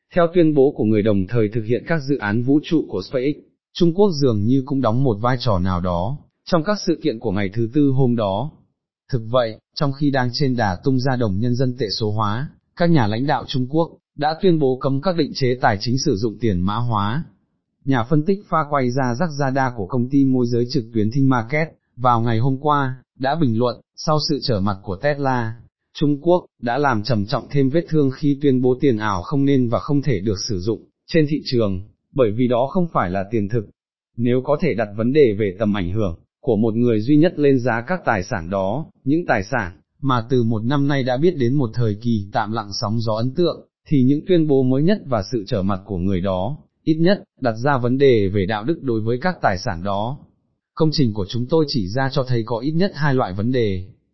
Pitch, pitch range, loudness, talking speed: 125 Hz, 110-145 Hz, -20 LUFS, 245 wpm